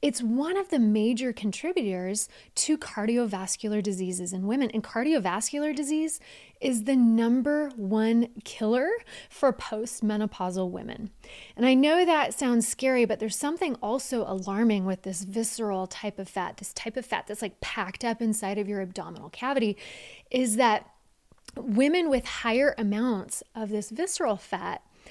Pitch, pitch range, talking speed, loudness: 225 Hz, 205-260 Hz, 150 wpm, -27 LUFS